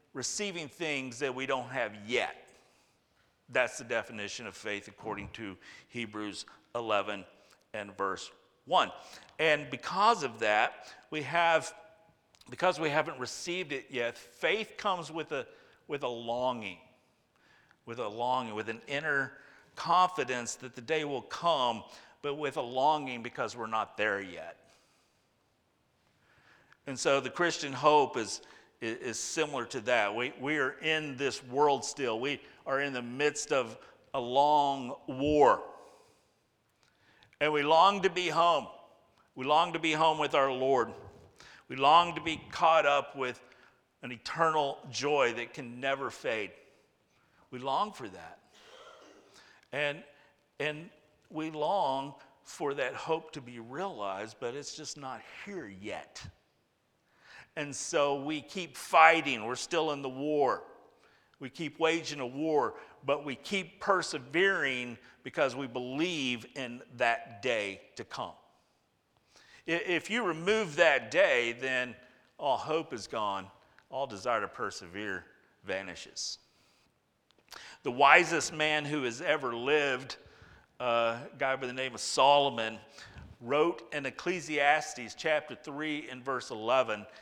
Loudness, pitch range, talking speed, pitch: -31 LUFS, 125-155 Hz, 135 wpm, 140 Hz